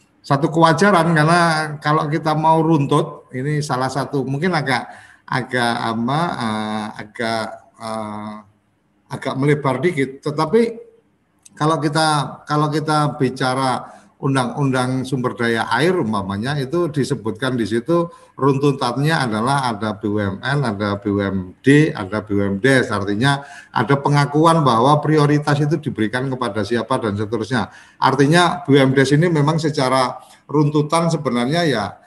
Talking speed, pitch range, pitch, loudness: 110 wpm, 115-150 Hz, 135 Hz, -18 LUFS